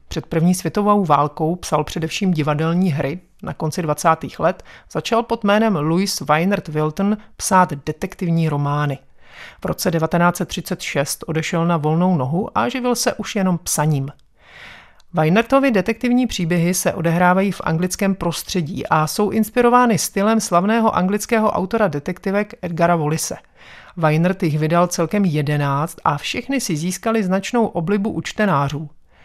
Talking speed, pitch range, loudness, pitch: 135 wpm, 155-205 Hz, -19 LUFS, 180 Hz